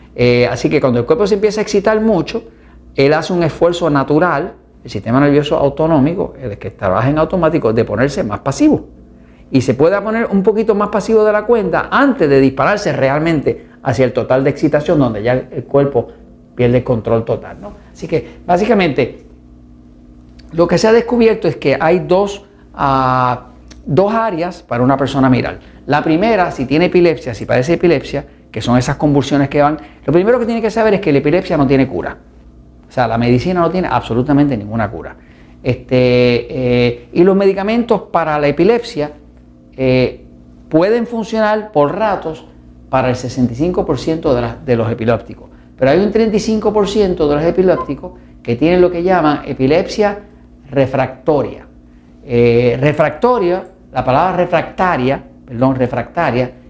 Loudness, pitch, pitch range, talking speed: -14 LUFS, 140 Hz, 120-180 Hz, 165 wpm